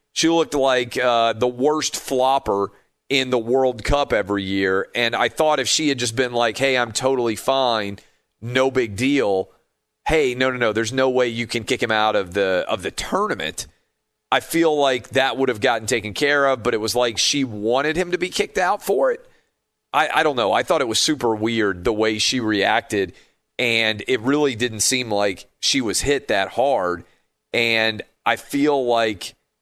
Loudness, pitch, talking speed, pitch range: -20 LUFS, 125 Hz, 200 wpm, 110-135 Hz